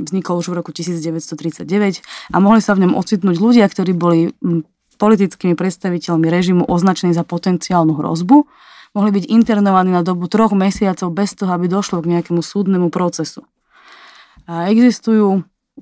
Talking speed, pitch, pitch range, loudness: 145 wpm, 185 Hz, 175-205 Hz, -15 LUFS